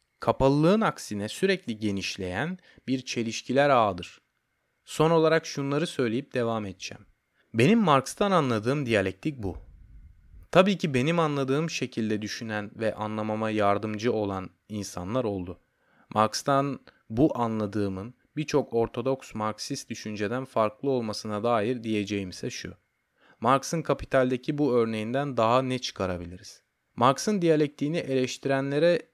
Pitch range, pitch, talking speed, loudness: 105-140 Hz, 120 Hz, 105 wpm, -27 LUFS